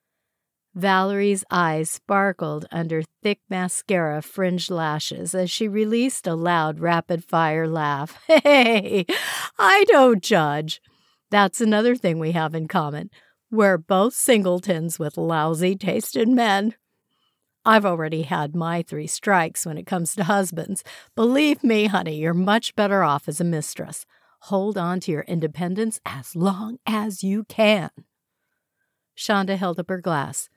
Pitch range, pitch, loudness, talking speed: 165-210 Hz, 185 Hz, -21 LUFS, 135 wpm